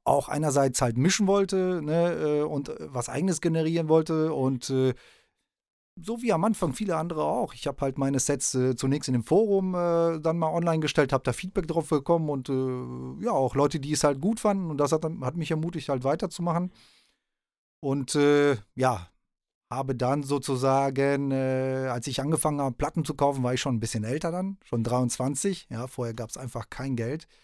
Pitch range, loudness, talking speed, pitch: 130-165 Hz, -27 LUFS, 190 wpm, 145 Hz